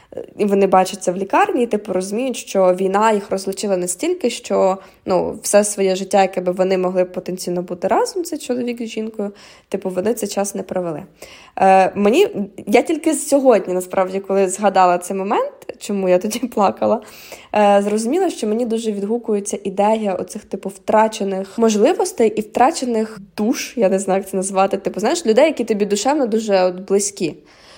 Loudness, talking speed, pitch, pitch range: -18 LUFS, 170 wpm, 205 Hz, 190-235 Hz